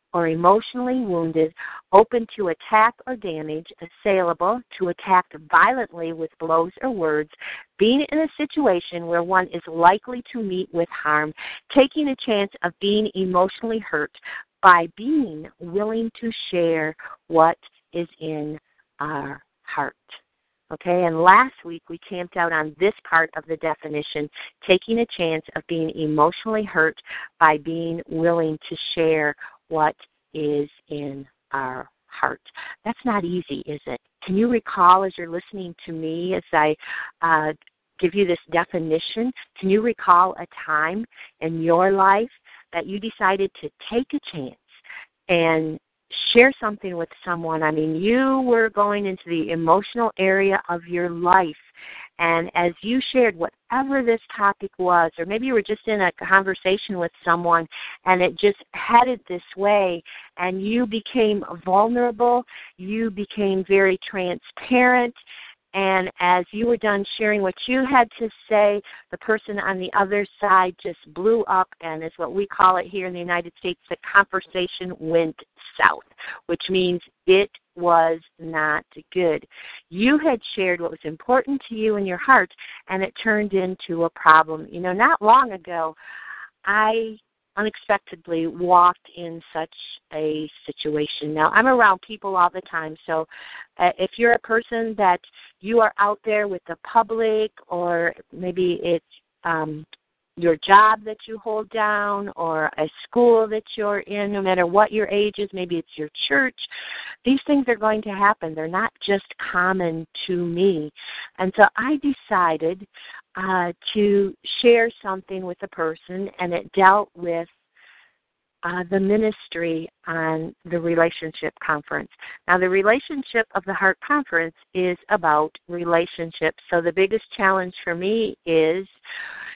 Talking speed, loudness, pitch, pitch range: 150 wpm, -21 LUFS, 185 Hz, 165-215 Hz